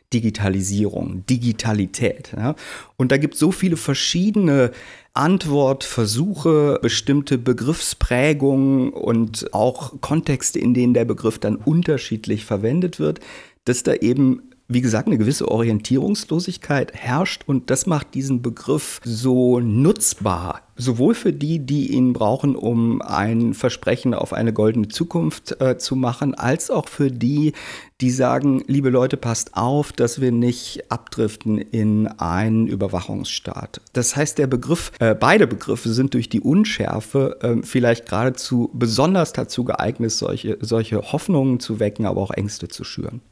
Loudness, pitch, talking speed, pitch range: -20 LUFS, 125 Hz, 135 wpm, 115-145 Hz